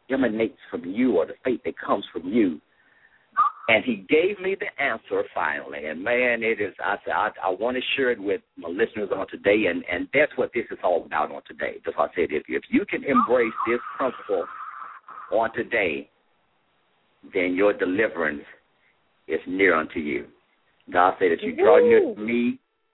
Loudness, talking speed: -24 LUFS, 185 wpm